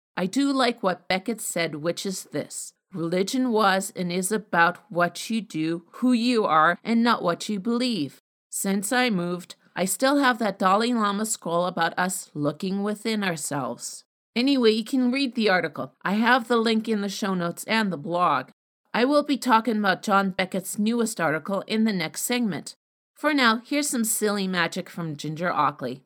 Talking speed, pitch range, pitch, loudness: 180 wpm, 175-230 Hz, 200 Hz, -24 LUFS